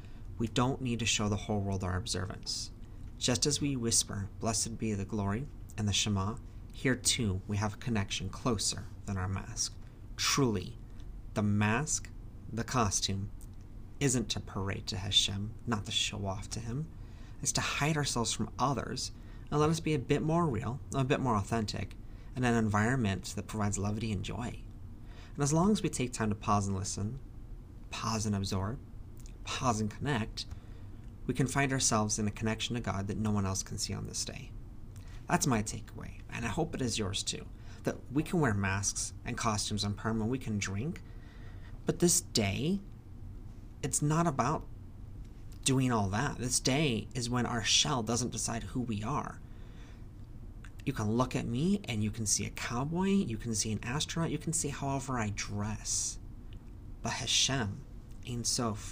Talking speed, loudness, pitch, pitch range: 180 wpm, -32 LUFS, 110 Hz, 105-120 Hz